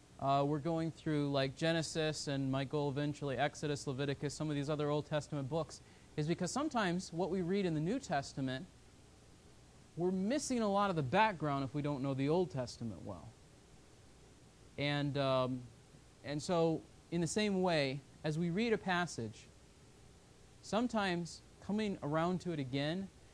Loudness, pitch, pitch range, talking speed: -37 LUFS, 150 Hz, 140-175 Hz, 160 wpm